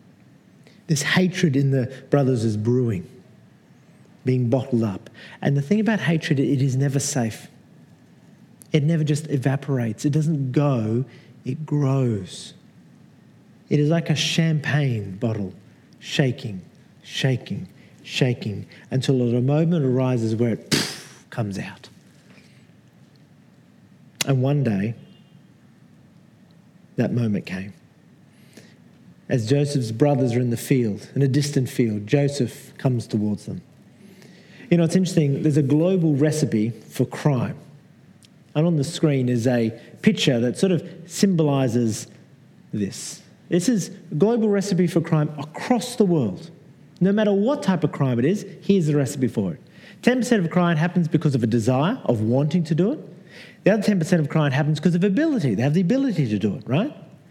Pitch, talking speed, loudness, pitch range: 145 Hz, 150 wpm, -22 LUFS, 125-175 Hz